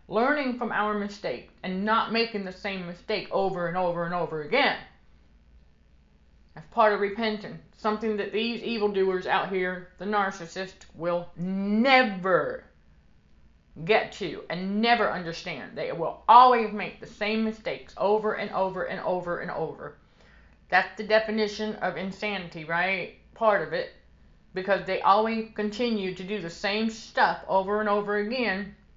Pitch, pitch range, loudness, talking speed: 195 Hz, 175-215 Hz, -26 LUFS, 145 wpm